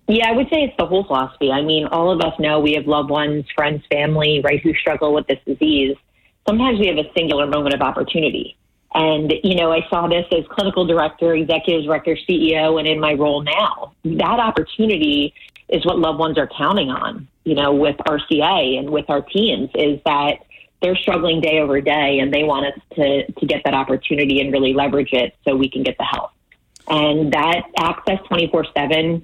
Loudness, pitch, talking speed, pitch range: -18 LUFS, 155 Hz, 200 wpm, 145-170 Hz